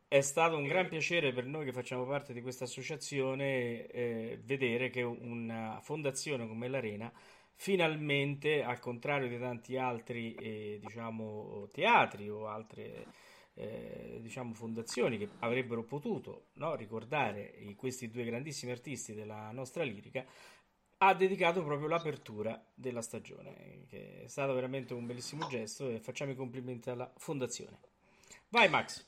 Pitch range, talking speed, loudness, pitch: 115-140 Hz, 140 wpm, -36 LUFS, 125 Hz